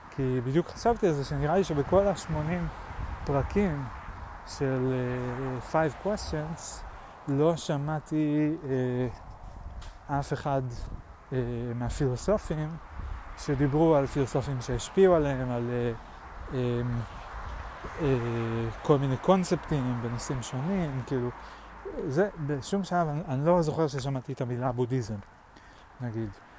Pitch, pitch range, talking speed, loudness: 135 Hz, 120-155 Hz, 110 wpm, -29 LUFS